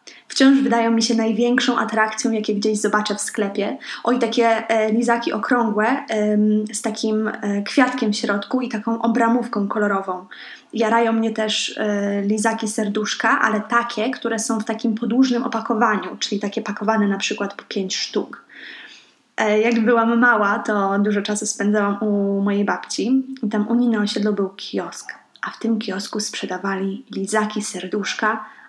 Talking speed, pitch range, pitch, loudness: 155 wpm, 210-230 Hz, 220 Hz, -20 LUFS